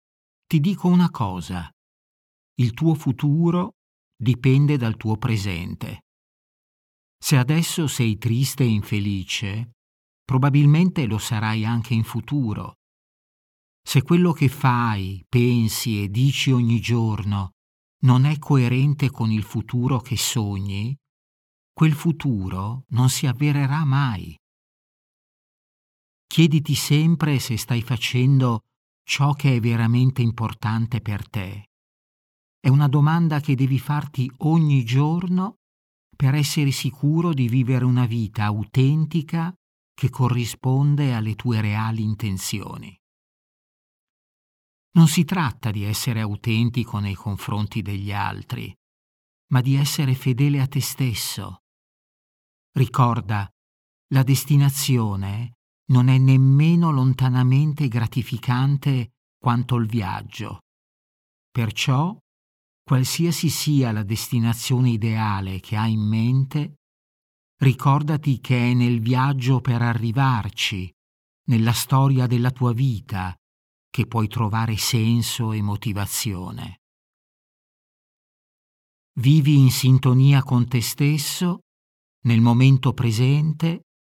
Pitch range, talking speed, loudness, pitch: 105-140 Hz, 105 wpm, -21 LUFS, 125 Hz